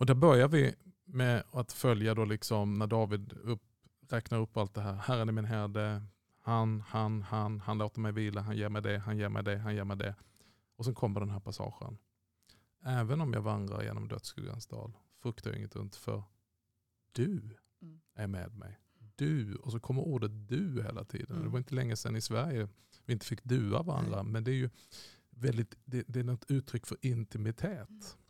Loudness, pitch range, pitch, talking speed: -35 LUFS, 105-125 Hz, 110 Hz, 200 wpm